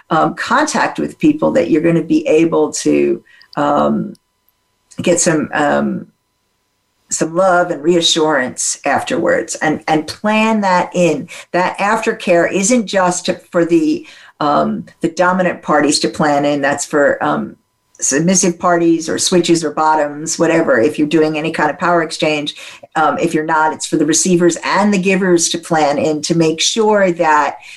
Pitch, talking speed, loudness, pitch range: 165 Hz, 160 wpm, -14 LUFS, 155-180 Hz